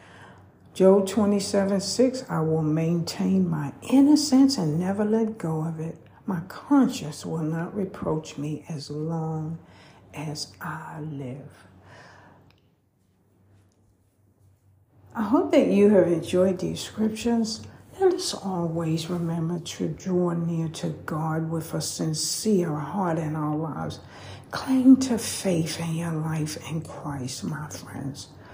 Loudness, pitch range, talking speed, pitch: -25 LUFS, 145-195 Hz, 125 wpm, 165 Hz